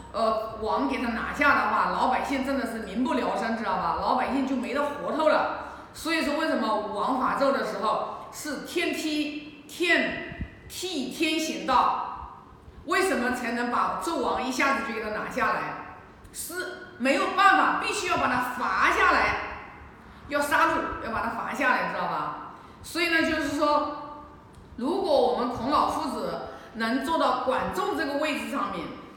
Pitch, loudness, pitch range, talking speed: 290 Hz, -26 LUFS, 250-320 Hz, 240 characters per minute